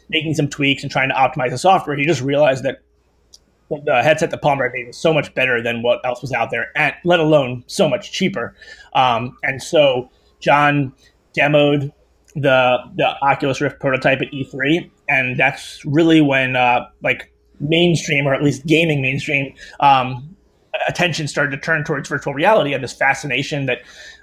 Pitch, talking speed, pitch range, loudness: 140 Hz, 175 wpm, 130-155 Hz, -17 LUFS